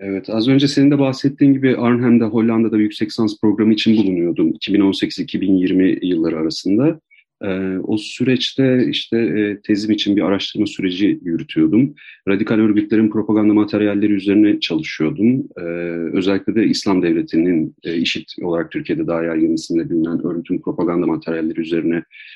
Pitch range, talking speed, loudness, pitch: 95-120 Hz, 140 wpm, -17 LUFS, 105 Hz